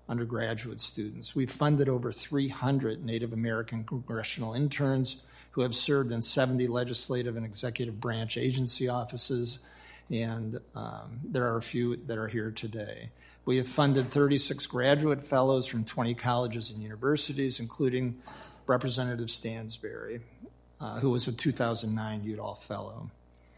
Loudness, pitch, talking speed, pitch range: -30 LUFS, 120 Hz, 130 wpm, 115-130 Hz